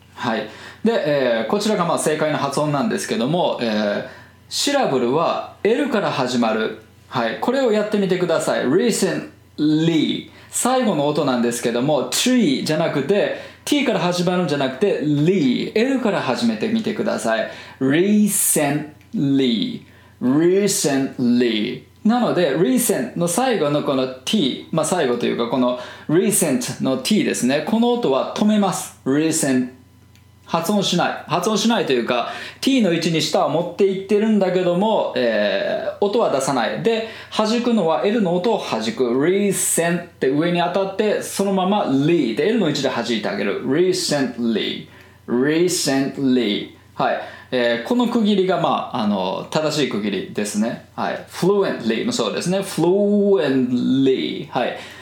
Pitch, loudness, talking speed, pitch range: 175 Hz, -19 LUFS, 350 characters per minute, 135-210 Hz